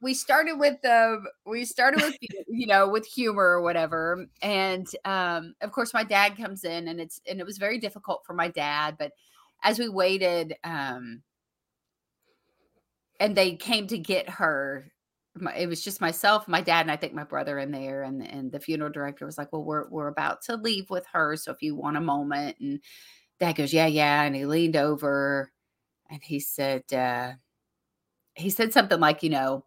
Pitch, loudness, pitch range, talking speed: 170 Hz, -26 LUFS, 145-205 Hz, 195 wpm